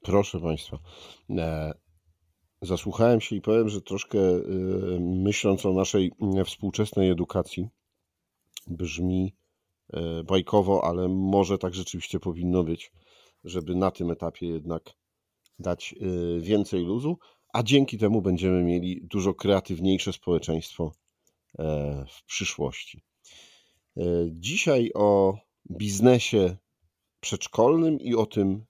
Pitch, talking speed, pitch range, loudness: 95 Hz, 95 wpm, 85-100 Hz, -26 LUFS